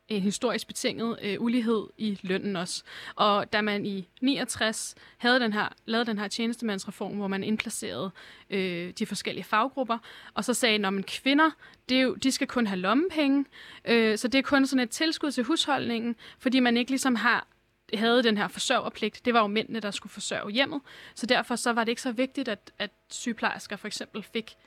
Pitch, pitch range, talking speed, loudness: 230 Hz, 205-250 Hz, 205 wpm, -27 LUFS